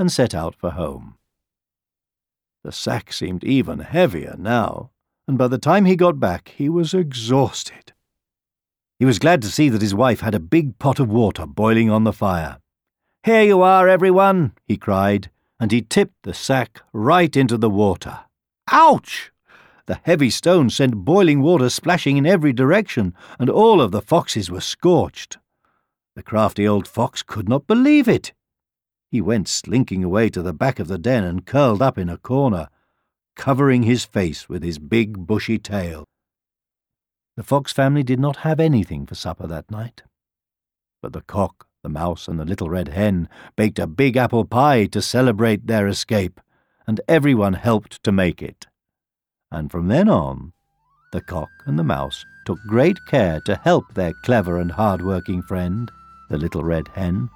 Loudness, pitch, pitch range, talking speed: -18 LUFS, 110 Hz, 90-135 Hz, 170 wpm